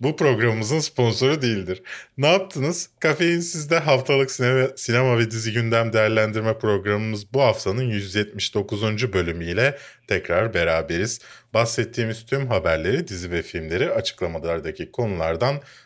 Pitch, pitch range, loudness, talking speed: 115 Hz, 105-135 Hz, -22 LUFS, 115 wpm